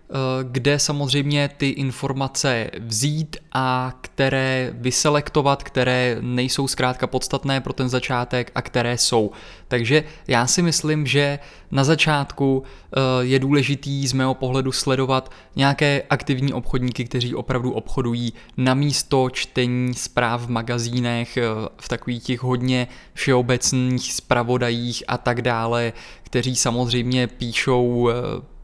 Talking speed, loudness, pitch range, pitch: 115 wpm, -21 LUFS, 125-140 Hz, 130 Hz